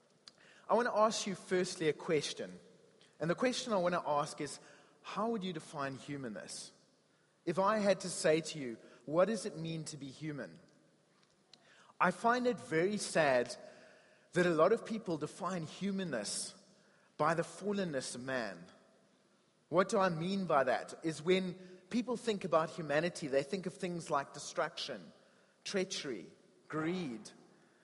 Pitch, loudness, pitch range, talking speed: 180 Hz, -36 LUFS, 155-200 Hz, 155 wpm